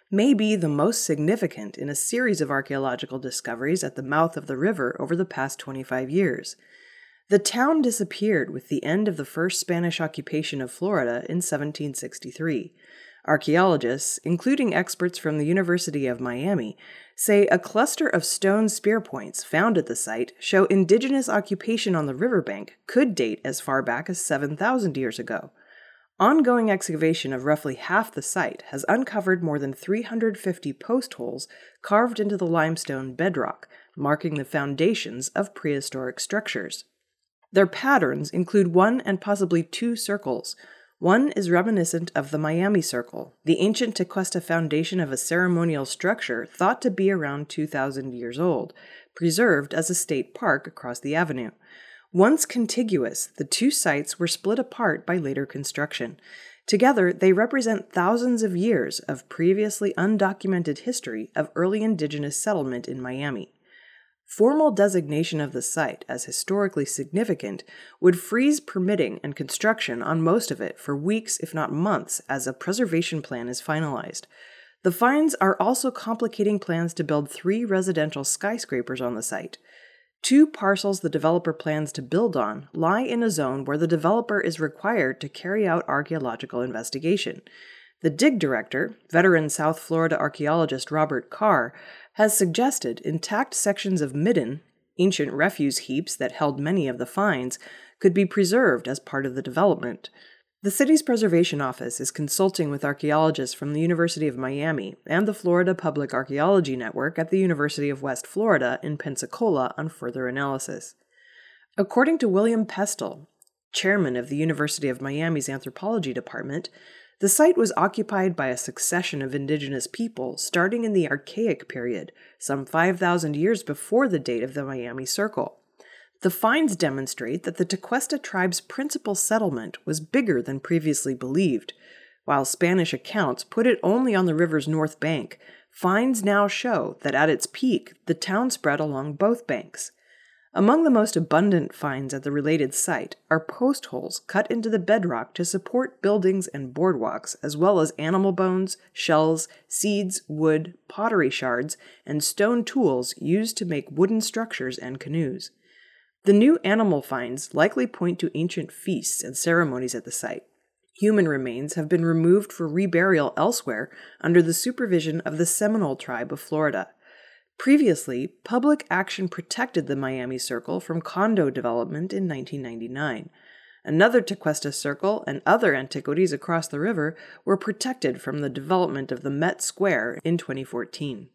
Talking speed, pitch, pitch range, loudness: 155 wpm, 170 Hz, 145-205 Hz, -24 LUFS